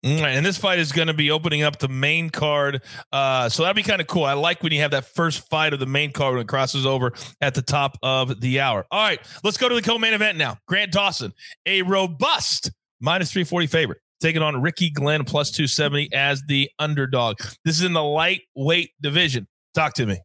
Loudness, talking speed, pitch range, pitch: -20 LUFS, 230 wpm, 135-170 Hz, 150 Hz